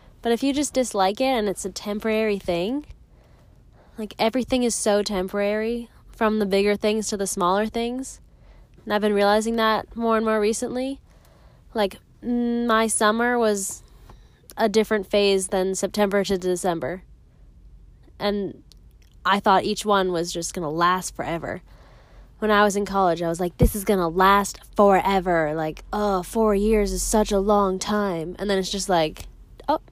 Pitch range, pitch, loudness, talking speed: 190-220 Hz, 205 Hz, -22 LUFS, 165 wpm